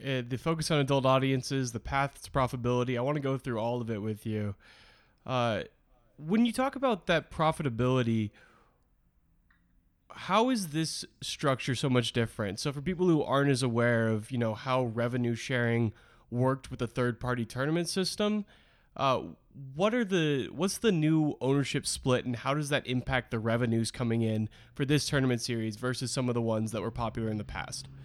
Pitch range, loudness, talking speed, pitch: 115-145 Hz, -30 LUFS, 185 wpm, 130 Hz